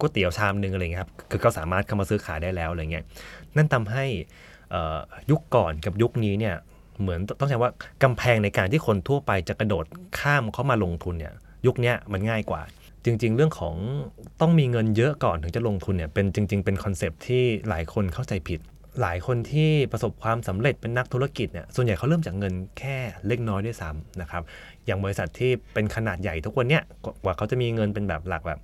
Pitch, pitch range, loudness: 105 Hz, 95-125 Hz, -26 LUFS